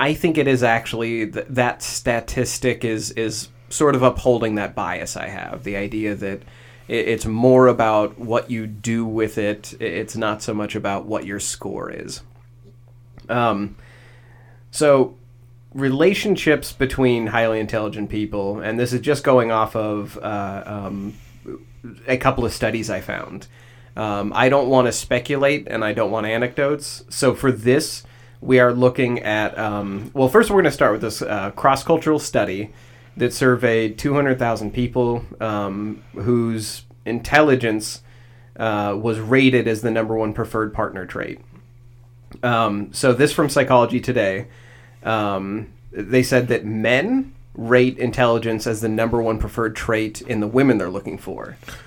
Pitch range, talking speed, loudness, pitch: 110-125 Hz, 155 wpm, -20 LUFS, 120 Hz